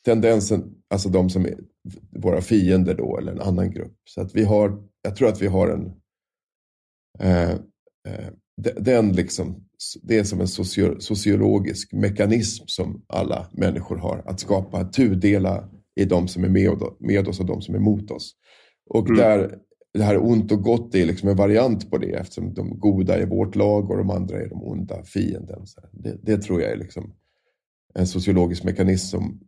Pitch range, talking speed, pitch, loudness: 95-105 Hz, 180 wpm, 100 Hz, -22 LUFS